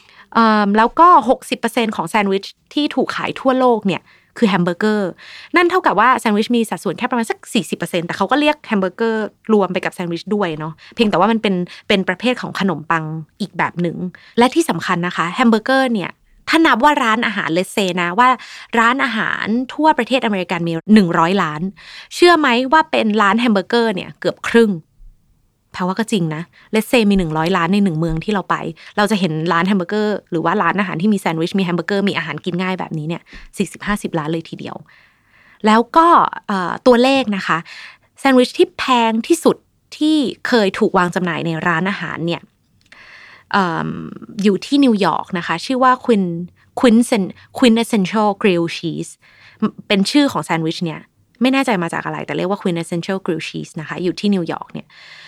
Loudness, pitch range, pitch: -16 LUFS, 175-235 Hz, 205 Hz